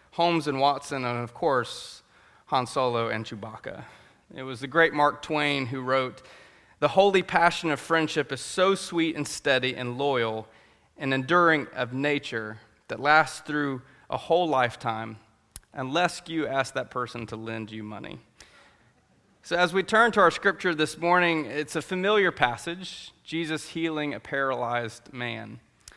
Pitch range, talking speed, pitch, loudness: 120-165 Hz, 155 wpm, 140 Hz, -26 LUFS